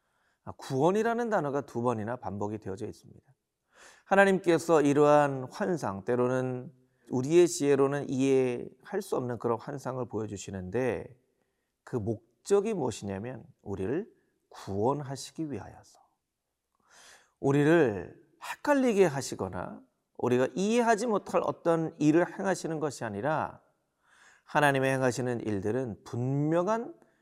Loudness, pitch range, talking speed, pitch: -29 LUFS, 120-165 Hz, 280 characters per minute, 135 Hz